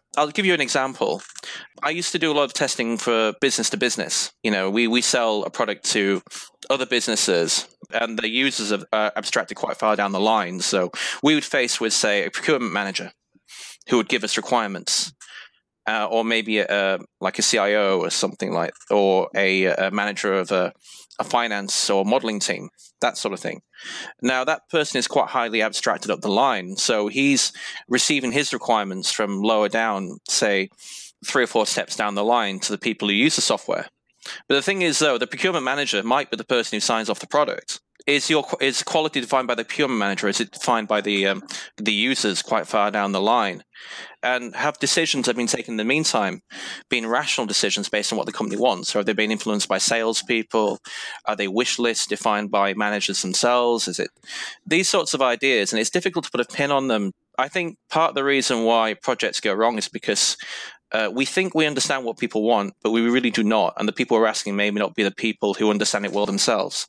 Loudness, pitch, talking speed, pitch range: -21 LUFS, 115 Hz, 215 wpm, 105-130 Hz